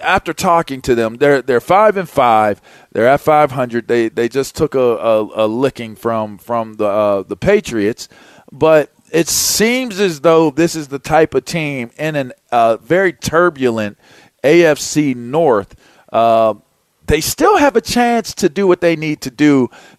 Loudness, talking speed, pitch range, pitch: -14 LUFS, 175 wpm, 115-170 Hz, 145 Hz